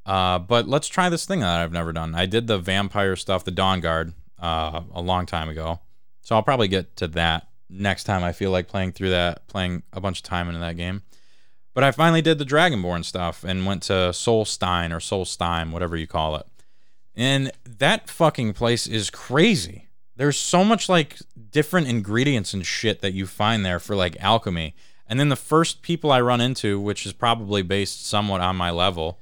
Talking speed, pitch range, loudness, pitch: 205 wpm, 90-120 Hz, -22 LUFS, 100 Hz